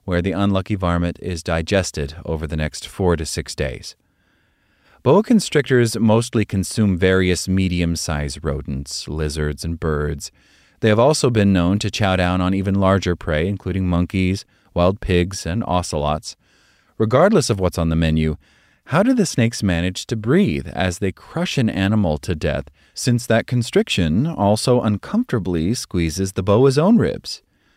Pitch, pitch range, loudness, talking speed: 95 Hz, 85-110 Hz, -19 LUFS, 155 wpm